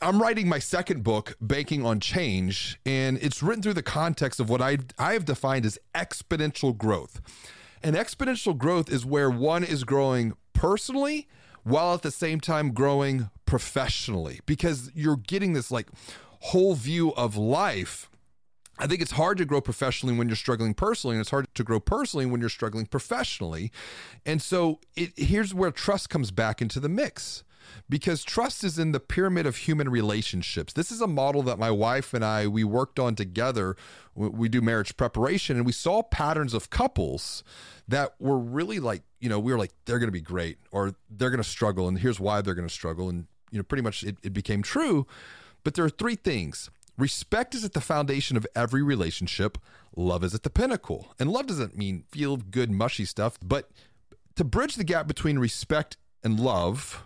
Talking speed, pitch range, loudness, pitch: 190 wpm, 110-155 Hz, -27 LUFS, 130 Hz